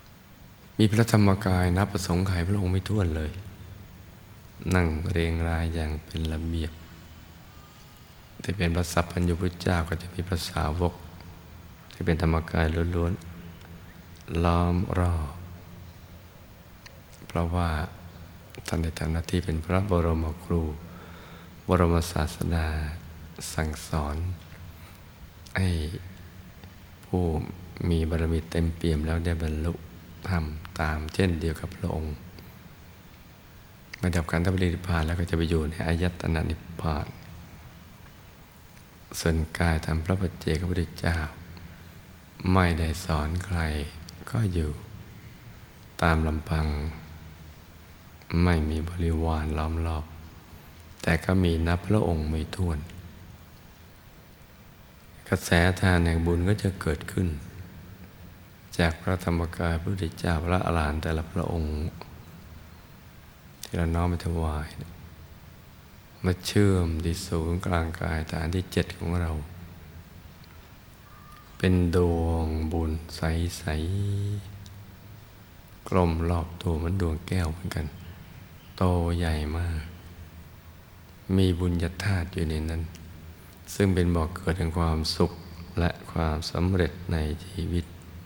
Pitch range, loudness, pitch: 80-90 Hz, -28 LUFS, 85 Hz